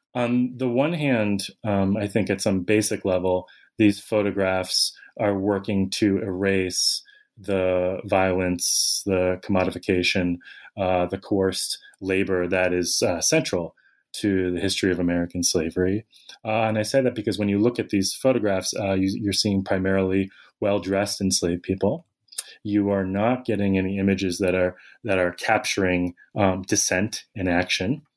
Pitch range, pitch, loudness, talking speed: 95-105 Hz, 95 Hz, -23 LUFS, 150 wpm